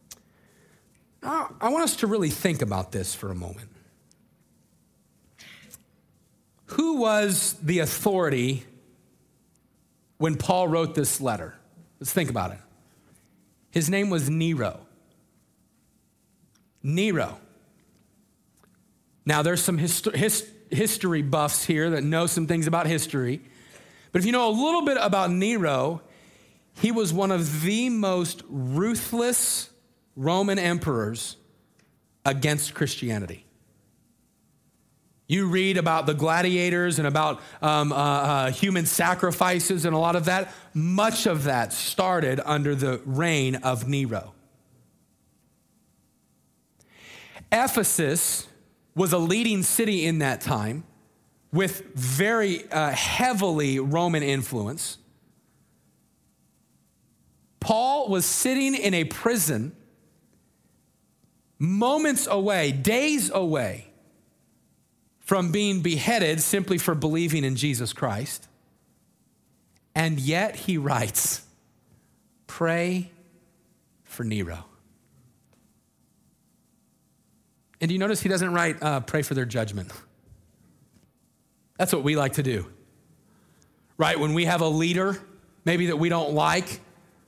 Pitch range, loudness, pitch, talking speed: 140-190 Hz, -24 LUFS, 165 Hz, 110 wpm